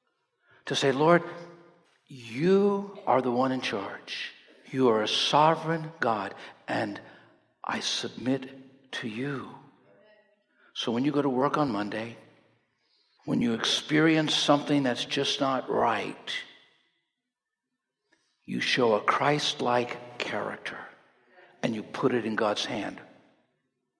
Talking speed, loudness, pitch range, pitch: 120 wpm, -27 LUFS, 130-170 Hz, 145 Hz